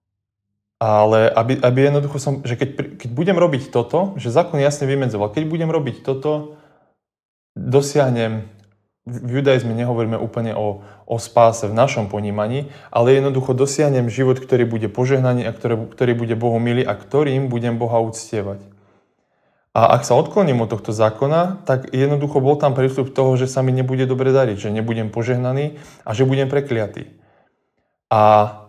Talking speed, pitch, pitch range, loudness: 155 wpm, 125 Hz, 115-140 Hz, -18 LUFS